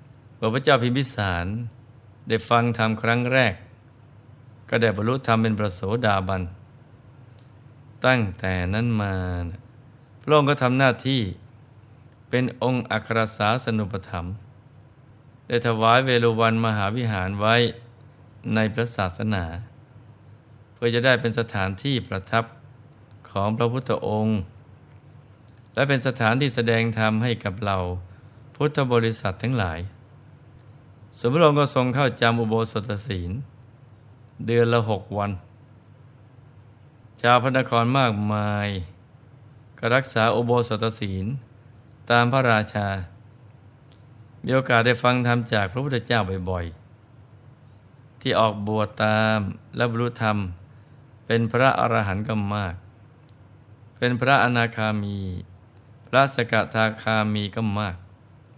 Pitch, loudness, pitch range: 115 Hz, -23 LUFS, 105-125 Hz